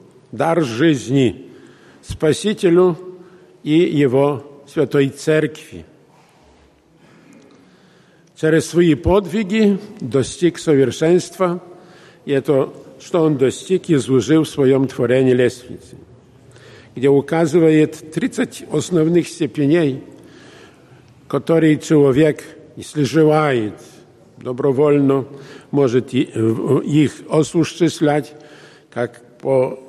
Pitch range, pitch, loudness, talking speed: 135-165 Hz, 150 Hz, -17 LUFS, 75 wpm